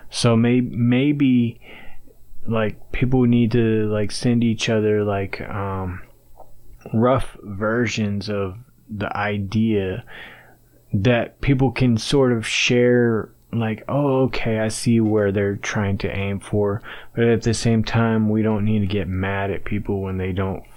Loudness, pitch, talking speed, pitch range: -21 LUFS, 110 Hz, 145 wpm, 100-120 Hz